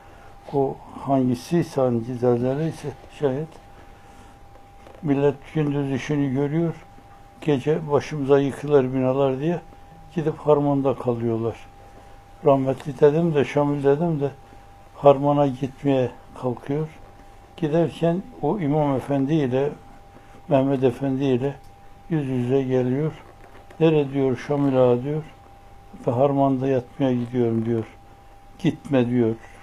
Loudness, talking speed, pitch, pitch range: -22 LUFS, 100 wpm, 135 Hz, 115-145 Hz